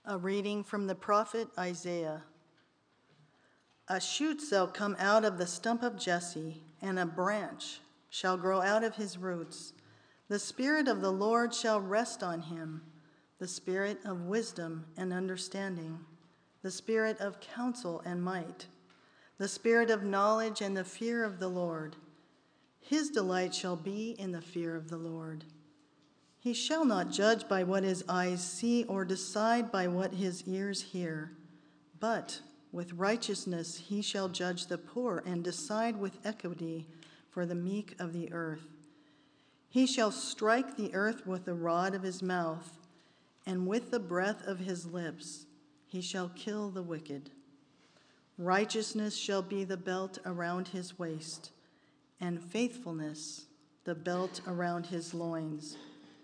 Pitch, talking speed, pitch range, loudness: 185 Hz, 150 wpm, 165-205 Hz, -35 LUFS